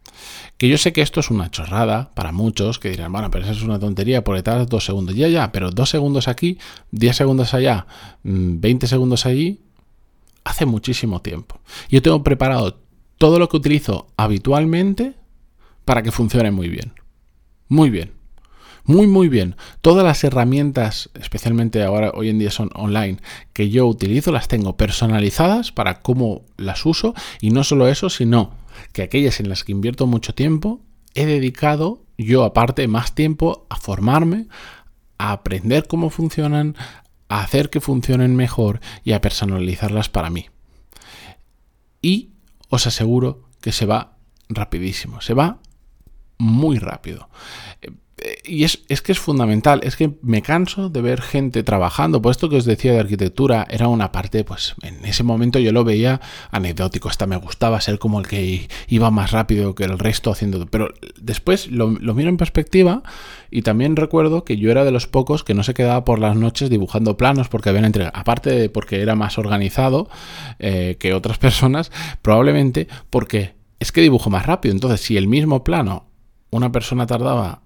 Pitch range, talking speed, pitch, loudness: 105-140 Hz, 170 wpm, 115 Hz, -18 LUFS